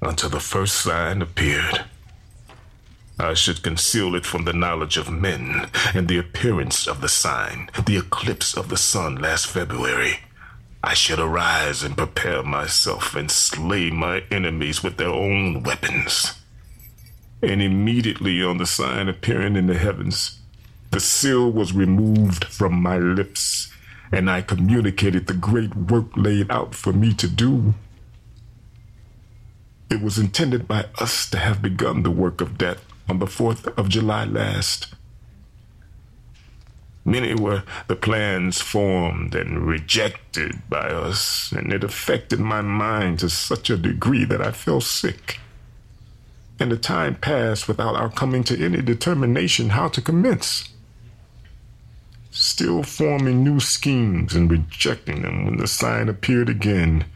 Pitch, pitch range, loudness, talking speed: 105 Hz, 90-115 Hz, -21 LUFS, 140 wpm